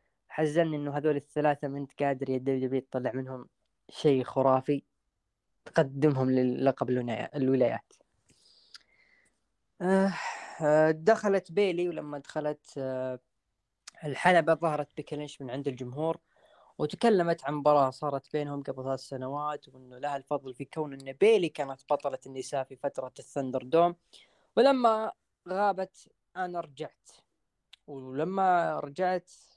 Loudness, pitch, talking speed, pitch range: -29 LUFS, 145 Hz, 105 wpm, 130-165 Hz